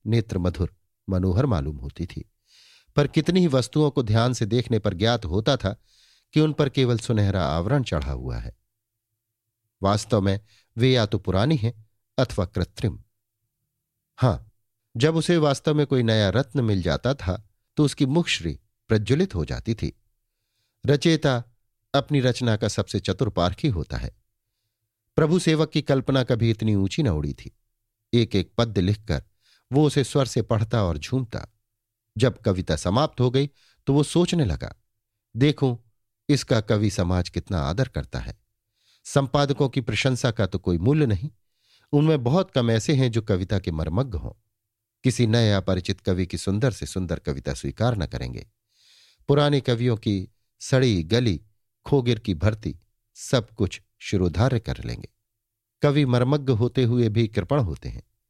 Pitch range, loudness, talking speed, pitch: 105-130 Hz, -24 LUFS, 155 wpm, 110 Hz